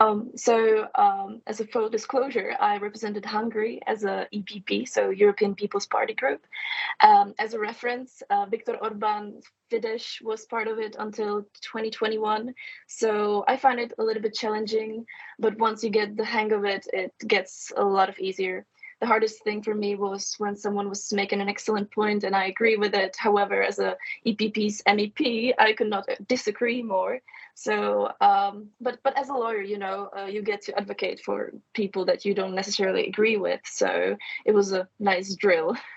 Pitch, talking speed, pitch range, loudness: 215 Hz, 185 wpm, 205-240 Hz, -26 LUFS